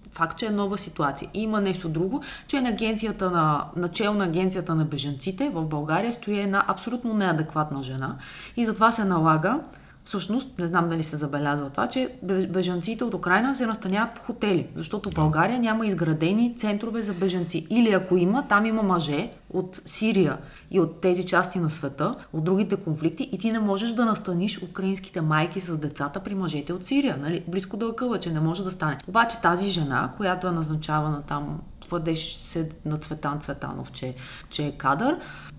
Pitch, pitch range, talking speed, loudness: 185 Hz, 160-210 Hz, 180 wpm, -25 LUFS